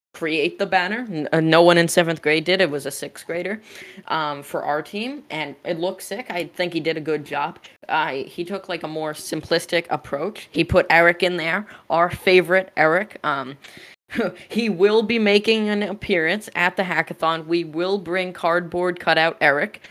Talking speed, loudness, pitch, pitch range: 185 wpm, -21 LUFS, 175 Hz, 160-195 Hz